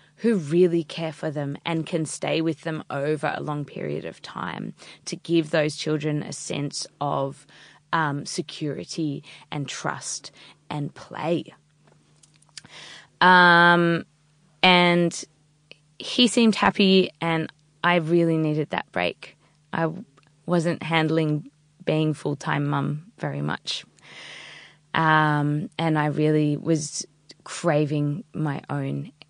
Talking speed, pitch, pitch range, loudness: 115 wpm, 155 Hz, 150-170 Hz, -23 LUFS